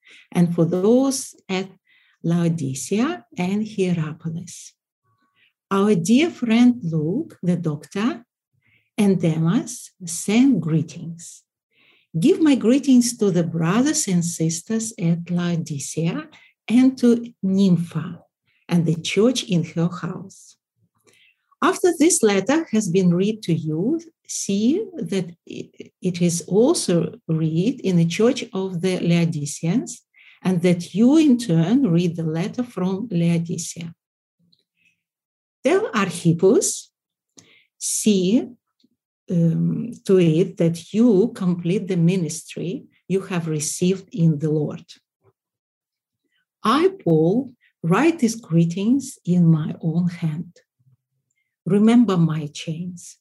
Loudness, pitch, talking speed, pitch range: -20 LUFS, 185 Hz, 105 wpm, 165-230 Hz